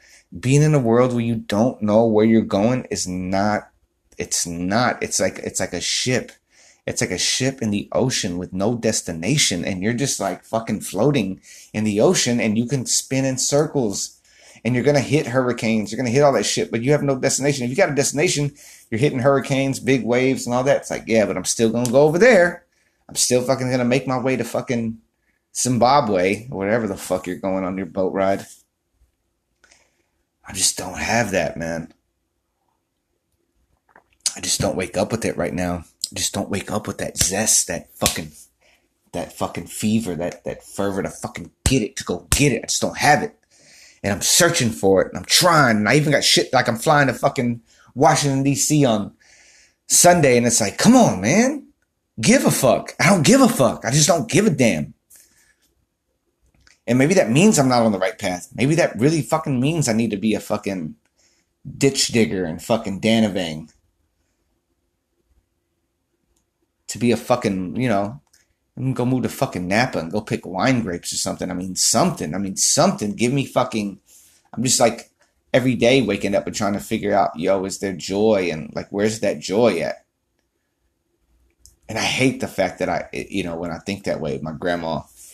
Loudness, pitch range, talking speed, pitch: -19 LUFS, 95-135 Hz, 200 wpm, 115 Hz